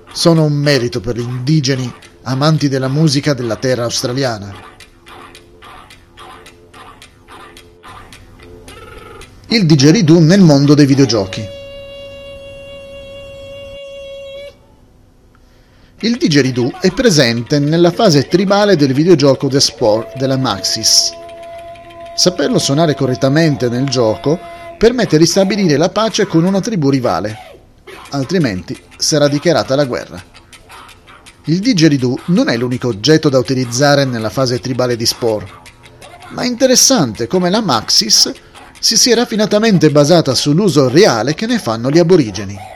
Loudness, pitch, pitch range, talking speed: -12 LUFS, 145 Hz, 120-200 Hz, 110 wpm